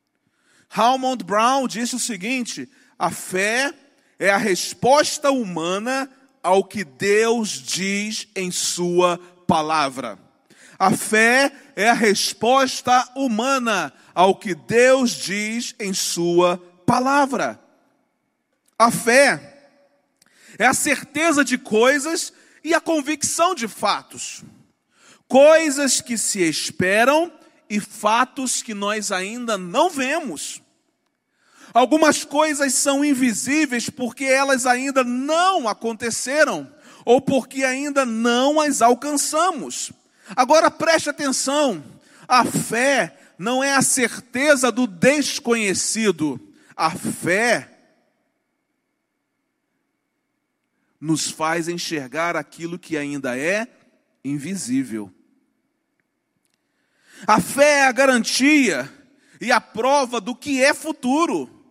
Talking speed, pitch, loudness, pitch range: 100 wpm, 260 Hz, -19 LUFS, 210-290 Hz